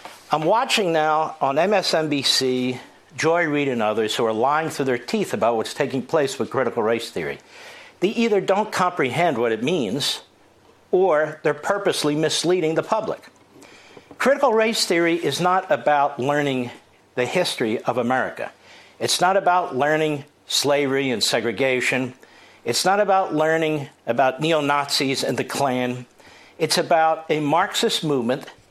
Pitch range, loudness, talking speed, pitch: 135-180 Hz, -21 LUFS, 145 wpm, 155 Hz